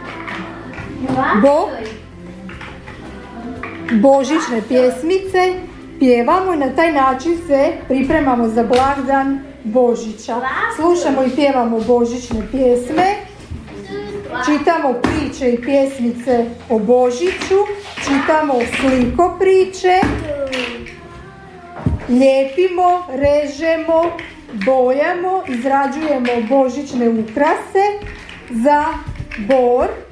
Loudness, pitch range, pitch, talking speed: -16 LUFS, 250-330 Hz, 275 Hz, 70 wpm